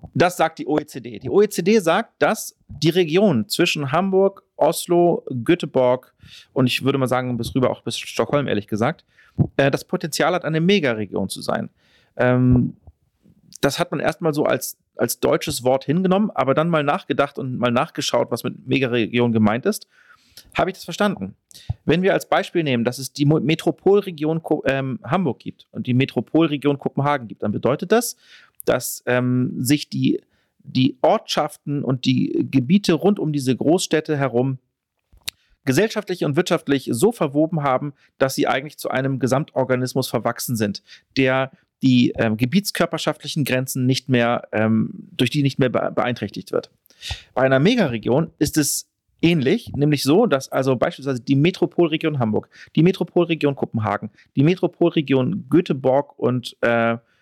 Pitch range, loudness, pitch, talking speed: 125-170 Hz, -20 LUFS, 145 Hz, 150 wpm